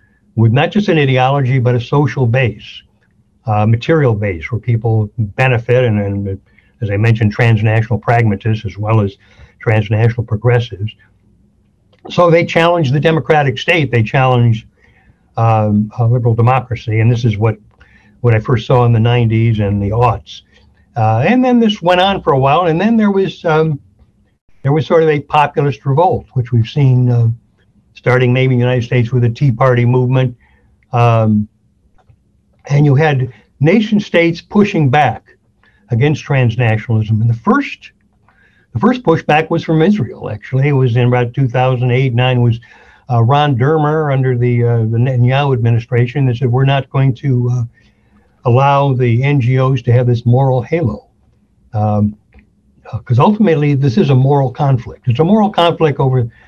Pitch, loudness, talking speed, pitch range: 125 Hz, -13 LUFS, 165 wpm, 110-140 Hz